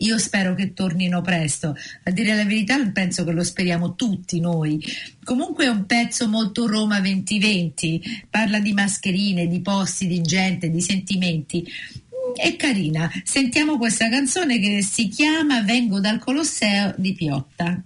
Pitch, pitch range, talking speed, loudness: 200 Hz, 175-230 Hz, 150 wpm, -21 LUFS